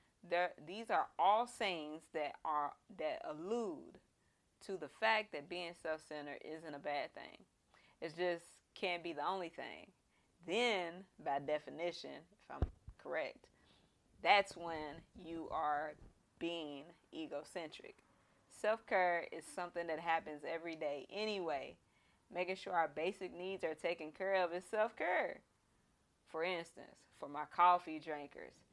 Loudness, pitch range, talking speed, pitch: -40 LUFS, 155-185 Hz, 140 wpm, 170 Hz